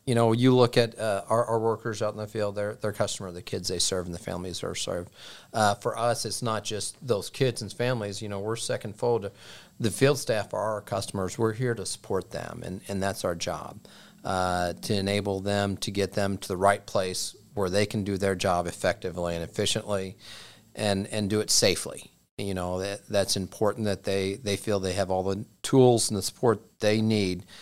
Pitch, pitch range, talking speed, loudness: 105 Hz, 95-110 Hz, 215 wpm, -28 LUFS